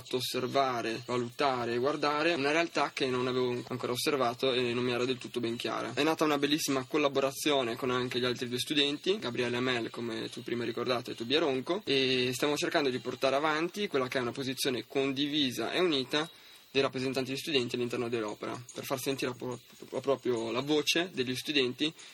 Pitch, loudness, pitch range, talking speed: 130 Hz, -31 LUFS, 125-145 Hz, 180 wpm